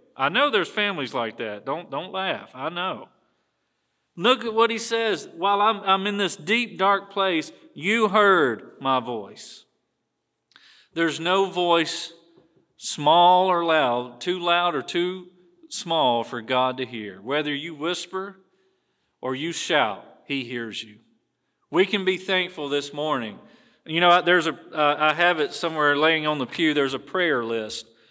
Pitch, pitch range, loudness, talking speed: 175 Hz, 145-195 Hz, -23 LUFS, 160 wpm